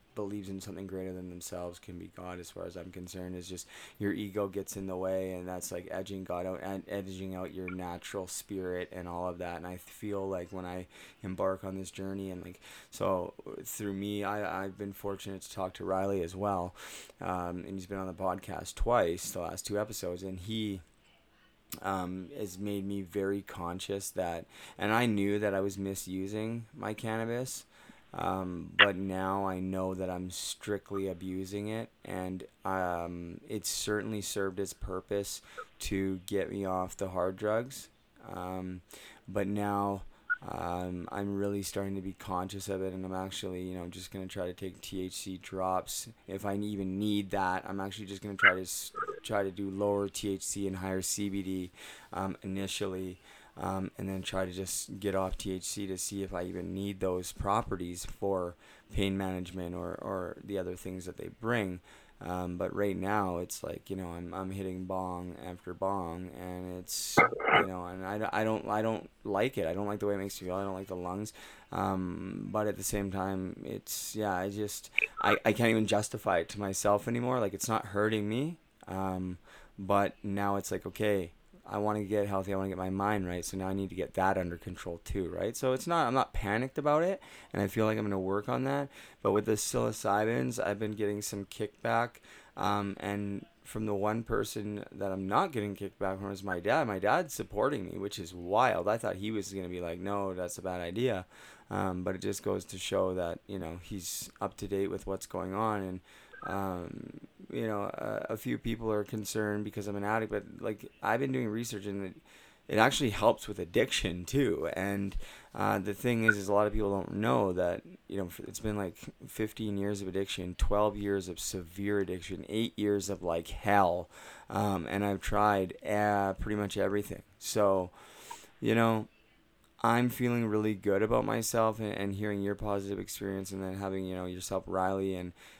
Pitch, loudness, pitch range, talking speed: 95 Hz, -34 LUFS, 95-105 Hz, 200 wpm